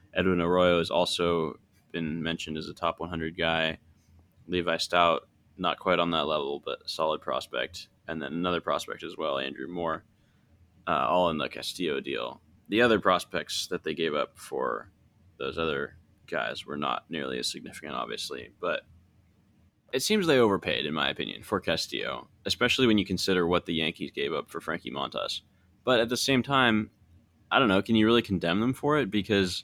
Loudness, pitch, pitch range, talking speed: -28 LUFS, 90 Hz, 80-105 Hz, 185 wpm